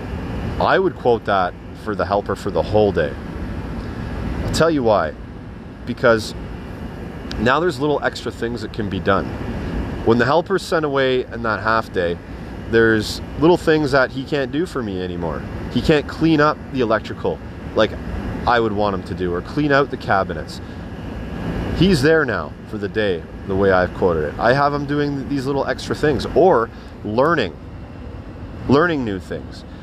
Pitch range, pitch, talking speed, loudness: 90-135 Hz, 105 Hz, 175 wpm, -19 LUFS